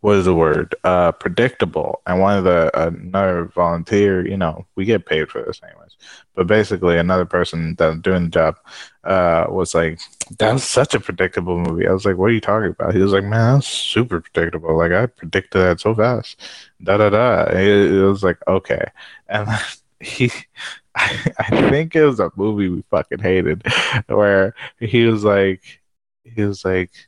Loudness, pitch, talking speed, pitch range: -17 LUFS, 95 Hz, 190 wpm, 90-105 Hz